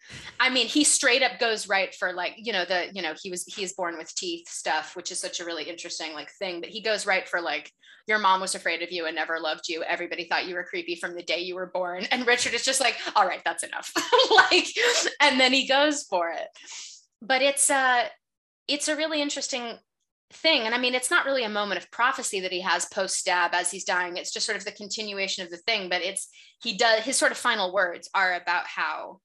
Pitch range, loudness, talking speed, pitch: 180-265 Hz, -25 LUFS, 245 wpm, 205 Hz